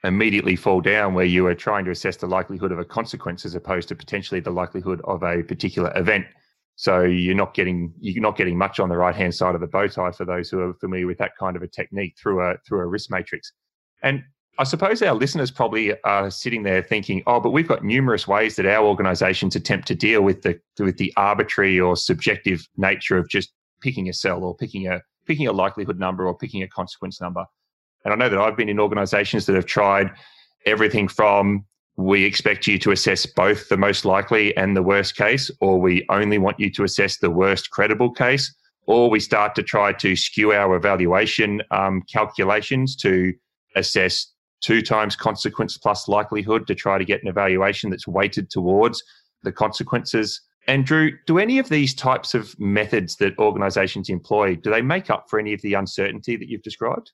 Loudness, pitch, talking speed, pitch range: -20 LUFS, 100 Hz, 205 wpm, 95-110 Hz